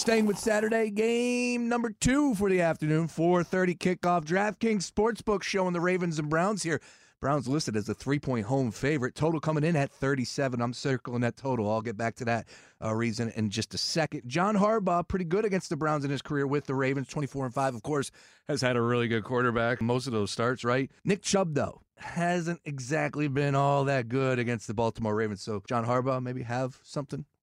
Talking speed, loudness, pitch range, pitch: 200 wpm, -29 LUFS, 125-175 Hz, 140 Hz